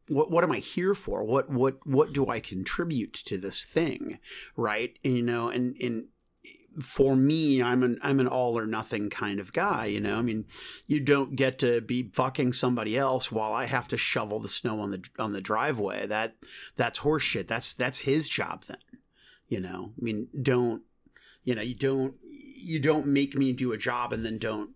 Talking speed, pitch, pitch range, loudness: 205 wpm, 125 Hz, 110-135 Hz, -28 LUFS